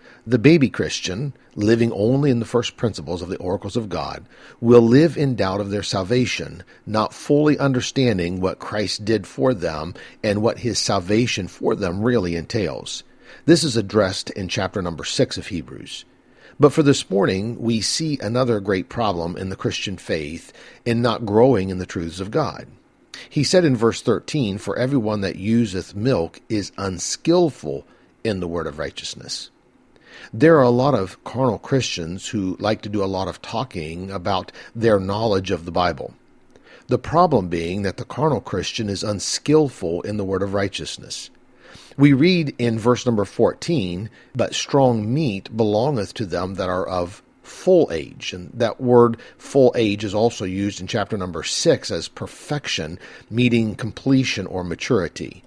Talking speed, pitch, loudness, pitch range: 165 wpm, 110 Hz, -21 LUFS, 95-125 Hz